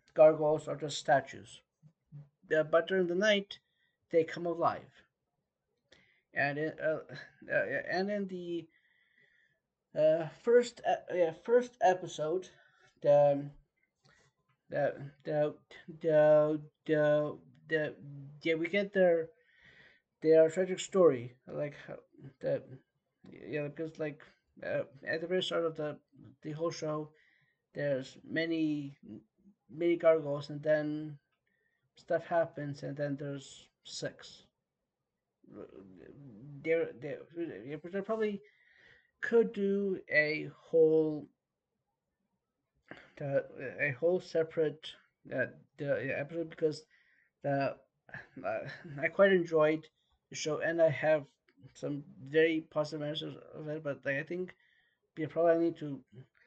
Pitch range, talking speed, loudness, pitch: 150-175 Hz, 110 wpm, -32 LUFS, 160 Hz